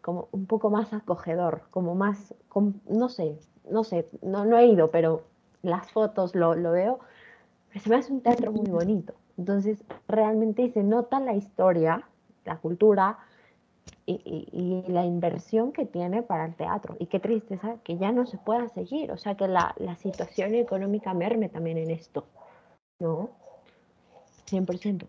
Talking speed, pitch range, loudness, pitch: 165 wpm, 175-225 Hz, -27 LUFS, 200 Hz